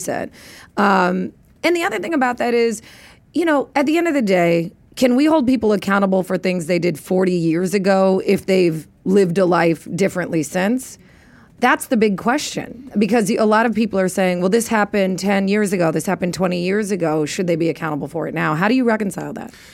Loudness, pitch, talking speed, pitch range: -18 LUFS, 195 Hz, 215 wpm, 180-230 Hz